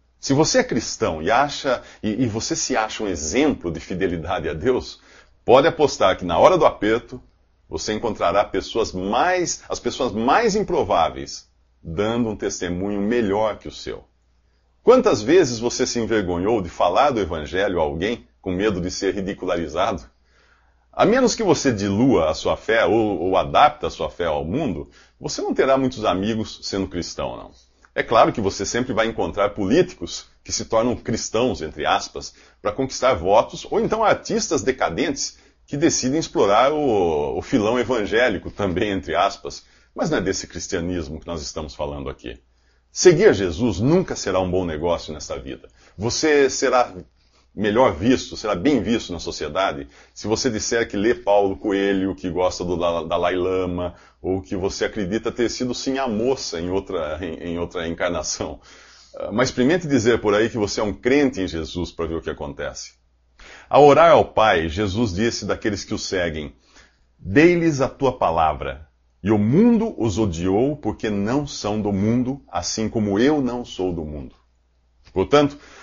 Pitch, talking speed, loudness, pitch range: 100 Hz, 170 wpm, -21 LUFS, 85-120 Hz